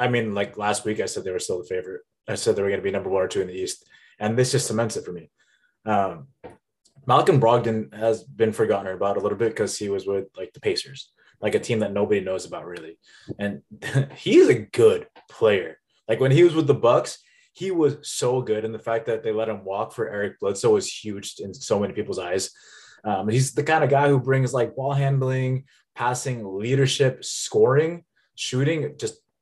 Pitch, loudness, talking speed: 135 Hz, -23 LUFS, 220 wpm